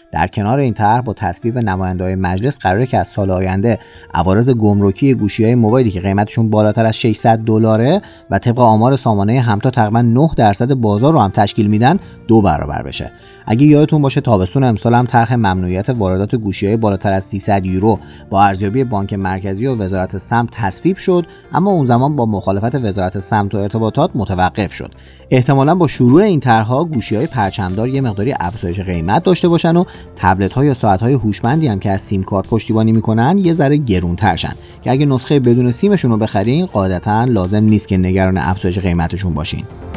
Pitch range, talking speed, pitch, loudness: 95-130 Hz, 185 wpm, 110 Hz, -14 LUFS